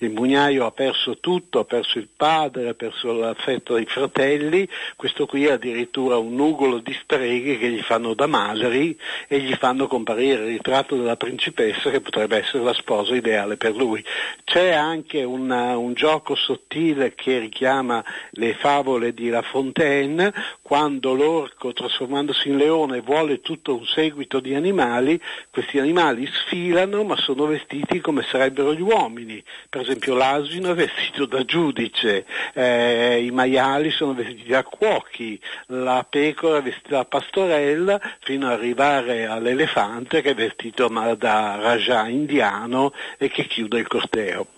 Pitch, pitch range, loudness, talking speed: 135 Hz, 120-150 Hz, -21 LUFS, 150 wpm